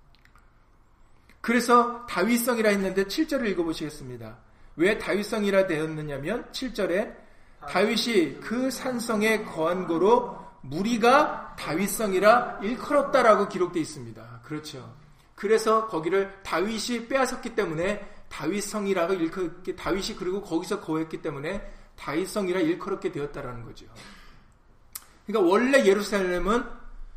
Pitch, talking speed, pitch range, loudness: 200 Hz, 305 characters per minute, 165-235 Hz, -25 LUFS